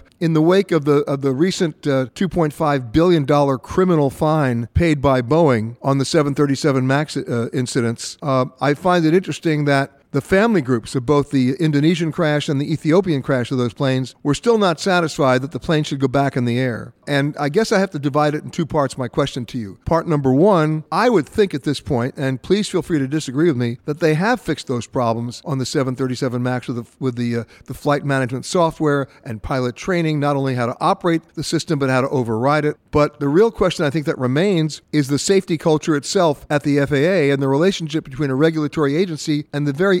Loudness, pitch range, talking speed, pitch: -18 LUFS, 135-160 Hz, 220 wpm, 145 Hz